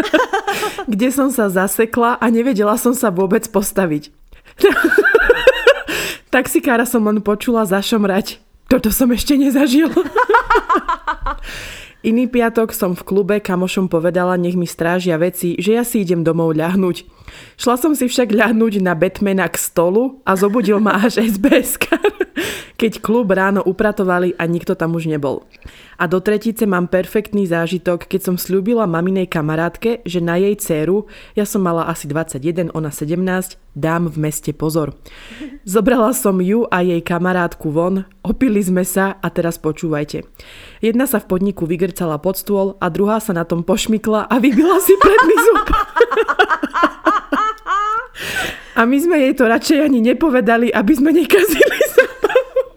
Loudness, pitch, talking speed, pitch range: -16 LUFS, 215 Hz, 145 wpm, 180-270 Hz